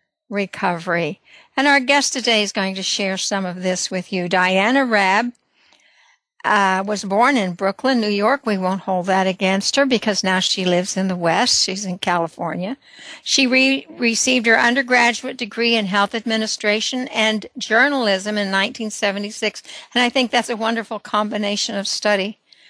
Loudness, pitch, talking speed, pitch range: -18 LUFS, 210 Hz, 160 wpm, 190-245 Hz